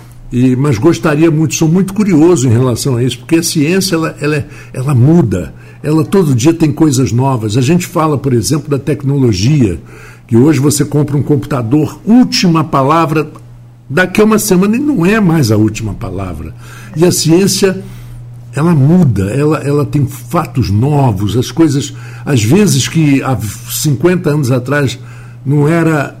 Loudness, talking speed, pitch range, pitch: -11 LUFS, 165 wpm, 120-160 Hz, 145 Hz